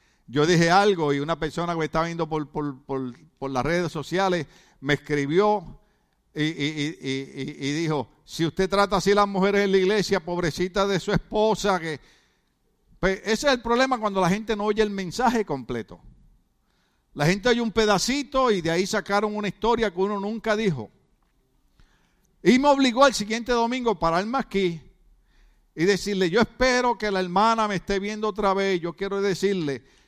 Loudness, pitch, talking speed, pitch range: -24 LUFS, 190 Hz, 185 wpm, 160-215 Hz